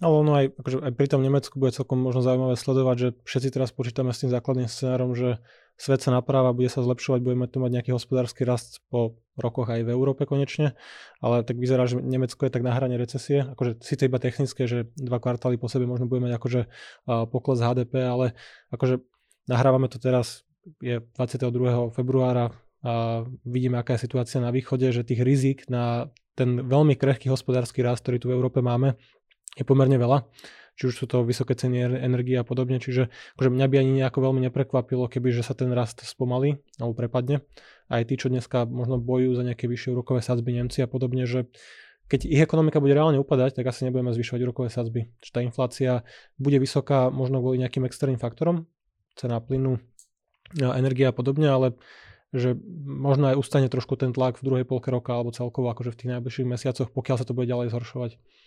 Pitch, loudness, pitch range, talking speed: 125 Hz, -25 LUFS, 125-130 Hz, 195 wpm